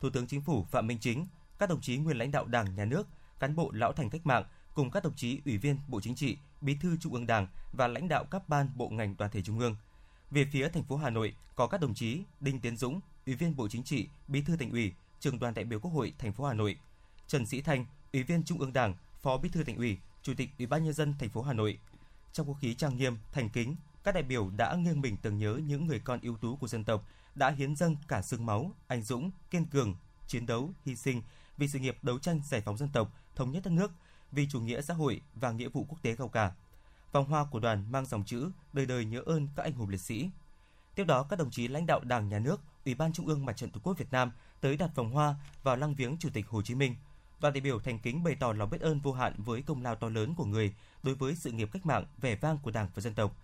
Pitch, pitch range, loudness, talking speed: 130 Hz, 115-150 Hz, -34 LUFS, 275 wpm